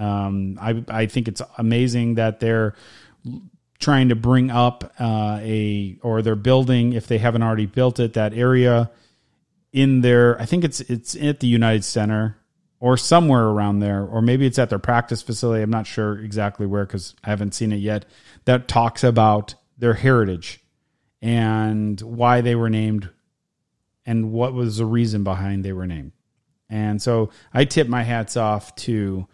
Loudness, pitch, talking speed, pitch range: -20 LUFS, 115 Hz, 170 wpm, 105-120 Hz